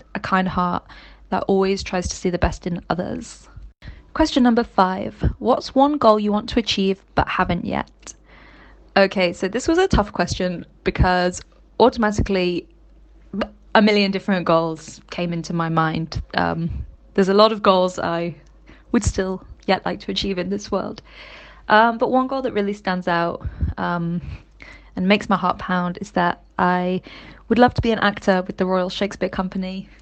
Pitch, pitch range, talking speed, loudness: 190 Hz, 180-210 Hz, 170 wpm, -20 LUFS